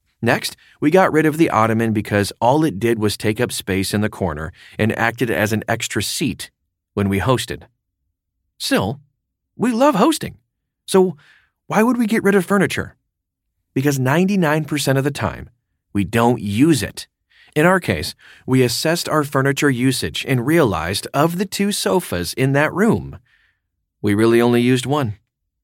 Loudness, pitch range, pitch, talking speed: -18 LUFS, 100-155 Hz, 120 Hz, 165 wpm